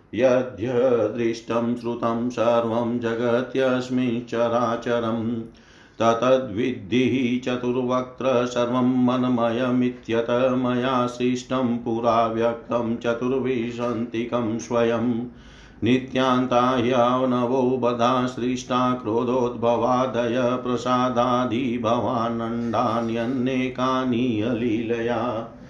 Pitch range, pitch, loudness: 115-125 Hz, 120 Hz, -23 LUFS